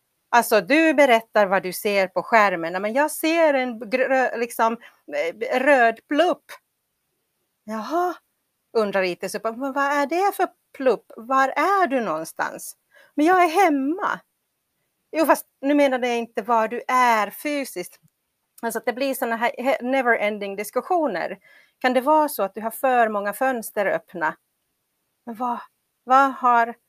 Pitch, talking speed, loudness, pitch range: 250 Hz, 145 wpm, -21 LUFS, 220-290 Hz